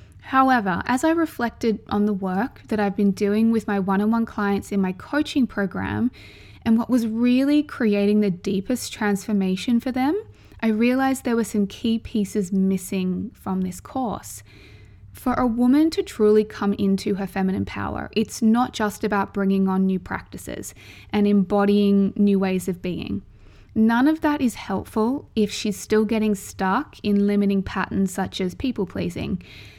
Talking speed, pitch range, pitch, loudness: 165 wpm, 190-235 Hz, 205 Hz, -22 LUFS